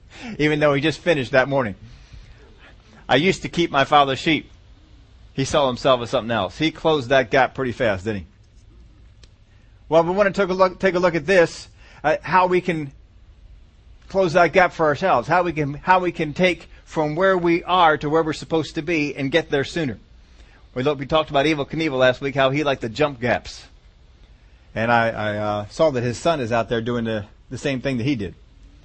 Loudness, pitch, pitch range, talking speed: -20 LUFS, 140 Hz, 110-165 Hz, 215 wpm